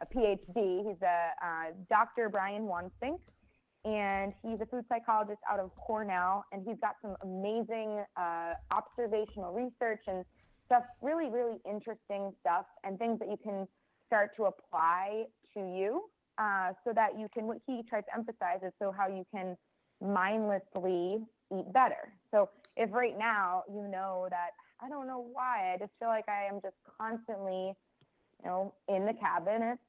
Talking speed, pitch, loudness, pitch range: 165 wpm, 205 Hz, -35 LUFS, 190-230 Hz